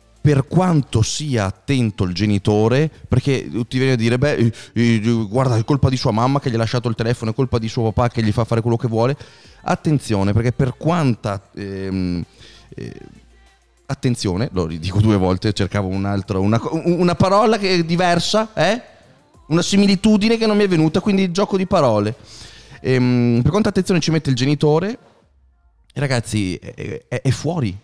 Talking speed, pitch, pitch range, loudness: 170 wpm, 120 Hz, 105-155 Hz, -18 LUFS